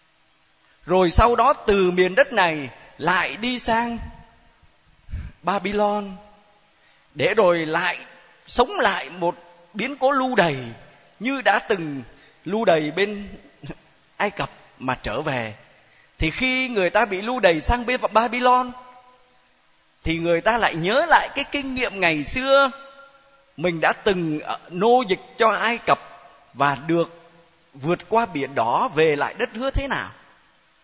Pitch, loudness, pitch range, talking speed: 200 Hz, -21 LUFS, 160-245 Hz, 140 wpm